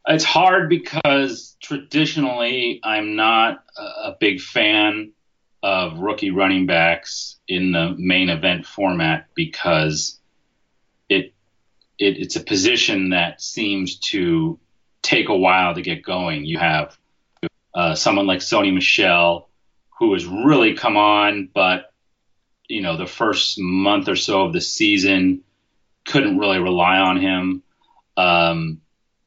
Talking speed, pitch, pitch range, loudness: 125 wpm, 95 Hz, 90-135 Hz, -18 LUFS